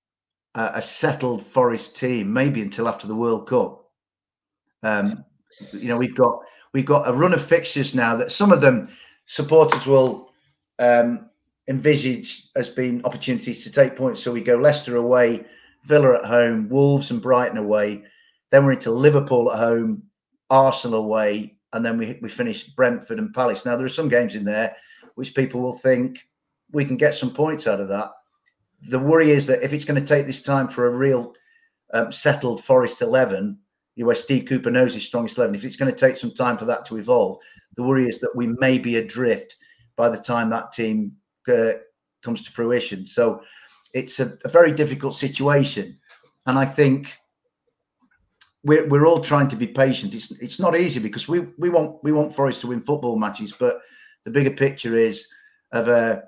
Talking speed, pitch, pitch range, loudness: 190 wpm, 130 Hz, 120-155 Hz, -20 LUFS